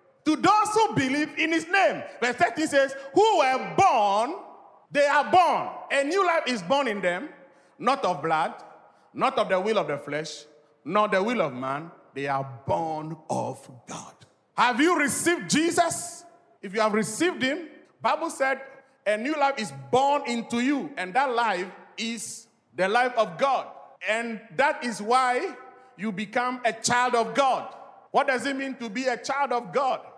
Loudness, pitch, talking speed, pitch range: -25 LUFS, 260 Hz, 175 wpm, 215-305 Hz